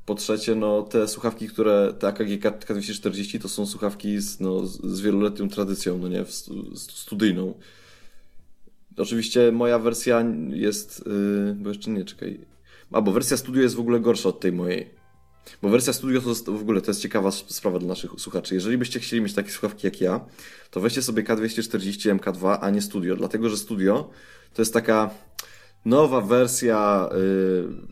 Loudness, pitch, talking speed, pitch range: -24 LUFS, 105 Hz, 170 wpm, 100-115 Hz